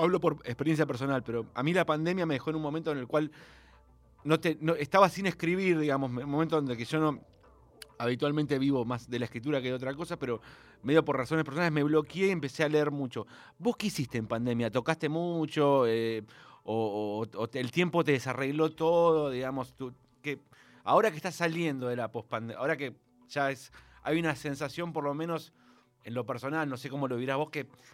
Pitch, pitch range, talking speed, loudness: 145 Hz, 125-160 Hz, 215 wpm, -31 LUFS